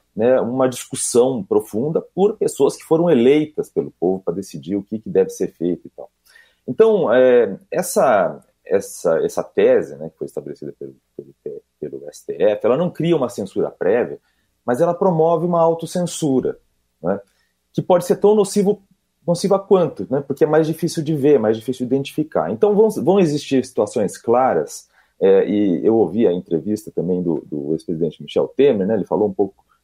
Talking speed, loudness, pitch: 175 wpm, -18 LUFS, 180 Hz